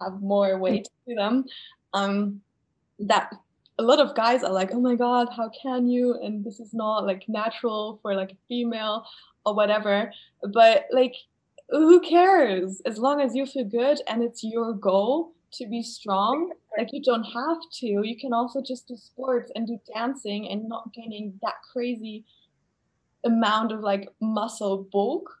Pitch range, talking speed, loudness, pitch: 210-255 Hz, 170 wpm, -25 LUFS, 230 Hz